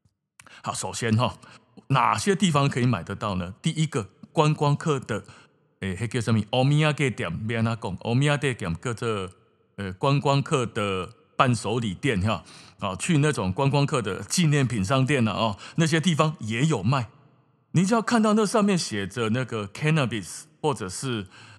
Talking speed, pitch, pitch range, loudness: 285 characters per minute, 125 Hz, 110-150 Hz, -25 LUFS